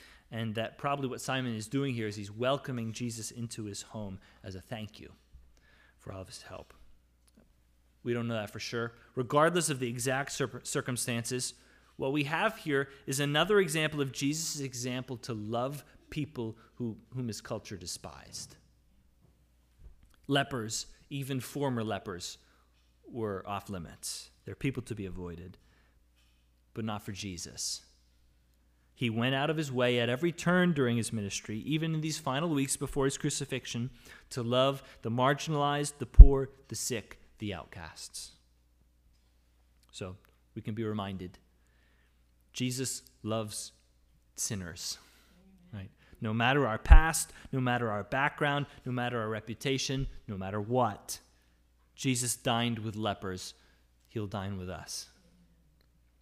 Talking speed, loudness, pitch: 140 wpm, -32 LUFS, 115 Hz